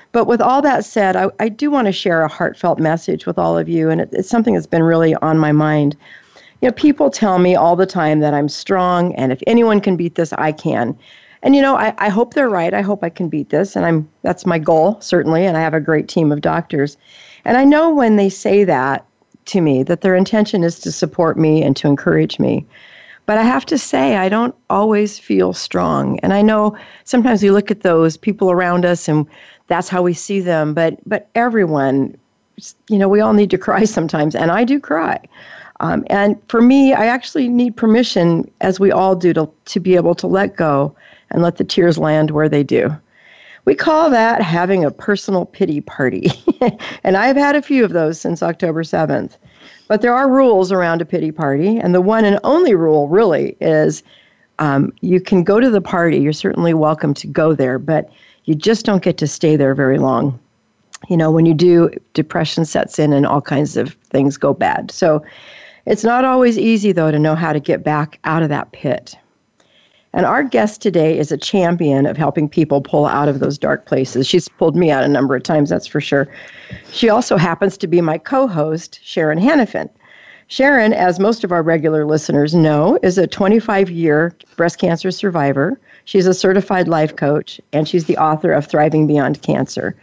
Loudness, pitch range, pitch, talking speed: -15 LUFS, 155-210 Hz, 175 Hz, 210 wpm